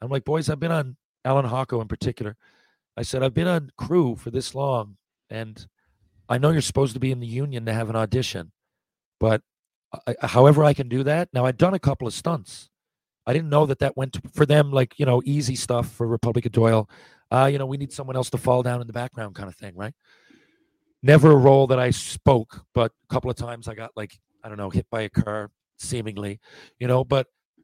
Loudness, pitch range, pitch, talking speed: -22 LUFS, 115-140 Hz, 125 Hz, 230 wpm